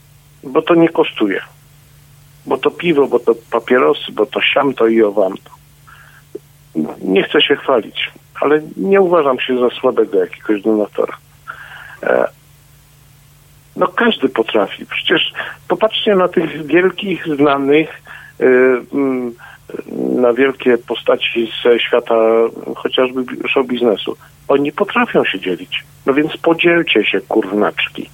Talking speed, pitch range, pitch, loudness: 115 wpm, 125-160 Hz, 145 Hz, -15 LUFS